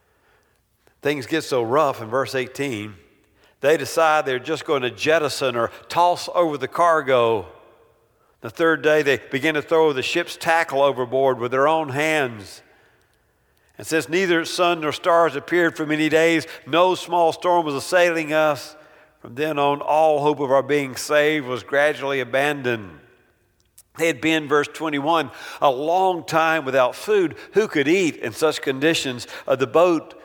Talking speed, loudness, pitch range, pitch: 160 wpm, -20 LUFS, 135-165 Hz, 155 Hz